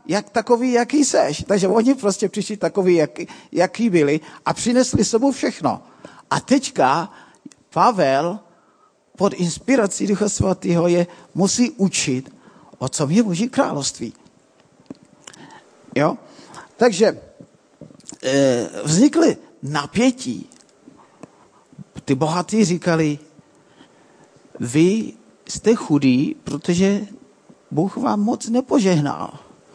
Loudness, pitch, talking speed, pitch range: -19 LUFS, 195 Hz, 95 wpm, 160-240 Hz